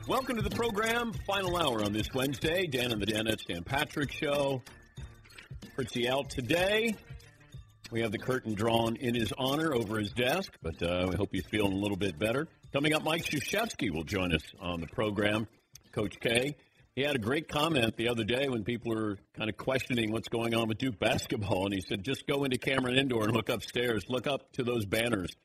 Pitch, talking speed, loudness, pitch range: 120 Hz, 210 wpm, -31 LUFS, 105-135 Hz